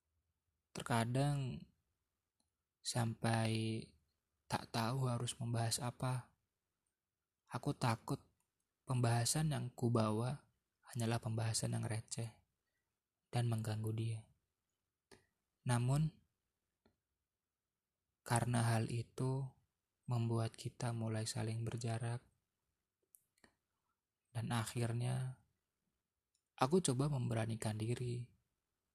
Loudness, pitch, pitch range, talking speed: -40 LUFS, 115 Hz, 110-125 Hz, 70 wpm